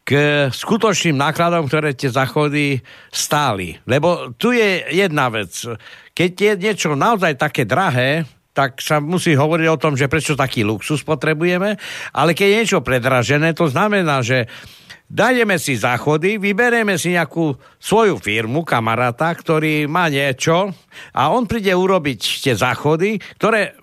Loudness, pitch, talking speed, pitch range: -17 LUFS, 155 Hz, 140 wpm, 140-185 Hz